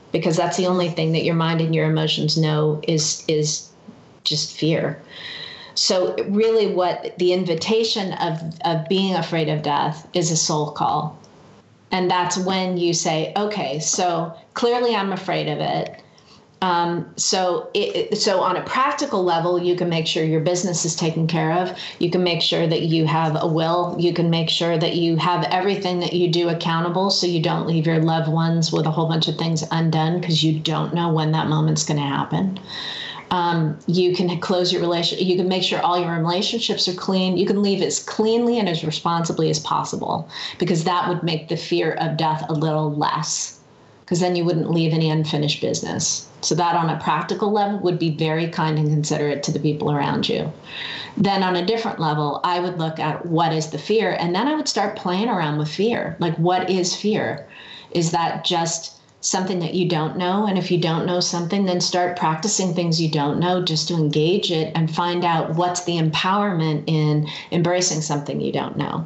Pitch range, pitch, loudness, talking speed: 160-180 Hz, 170 Hz, -21 LUFS, 200 wpm